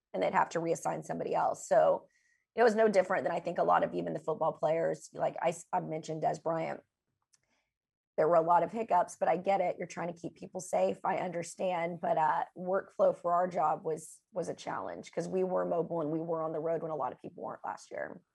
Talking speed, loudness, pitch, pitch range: 240 wpm, -32 LUFS, 175 Hz, 165-185 Hz